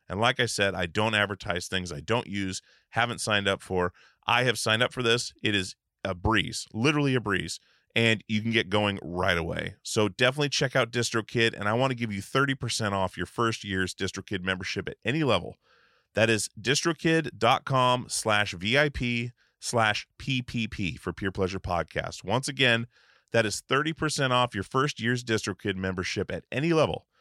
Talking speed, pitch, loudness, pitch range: 180 wpm, 110 Hz, -27 LUFS, 95-125 Hz